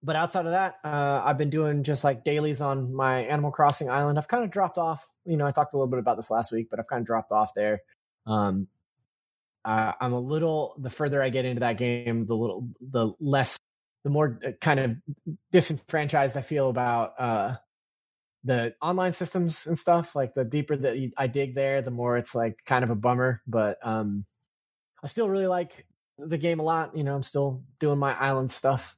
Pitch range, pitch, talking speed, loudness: 120-150 Hz, 140 Hz, 210 wpm, -27 LUFS